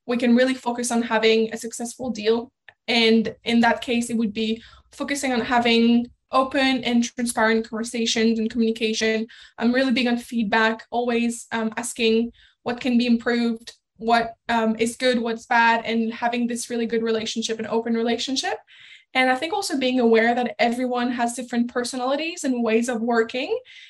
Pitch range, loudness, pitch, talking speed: 225-245 Hz, -22 LUFS, 235 Hz, 170 wpm